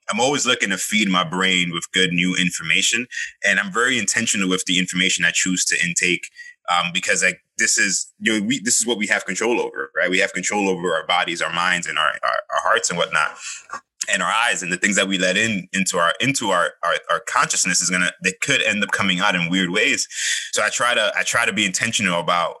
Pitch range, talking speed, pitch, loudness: 90-95 Hz, 240 wpm, 95 Hz, -19 LUFS